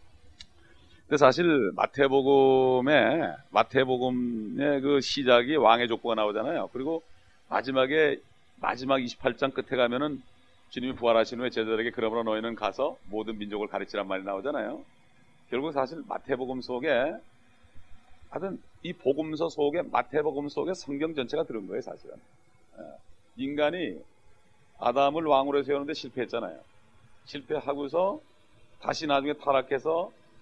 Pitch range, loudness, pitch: 110-140 Hz, -27 LUFS, 130 Hz